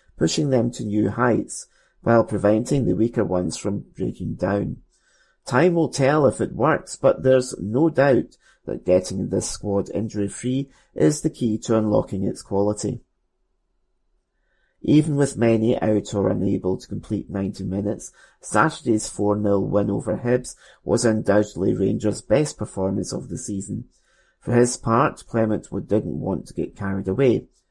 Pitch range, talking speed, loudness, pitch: 95-120 Hz, 150 wpm, -22 LUFS, 105 Hz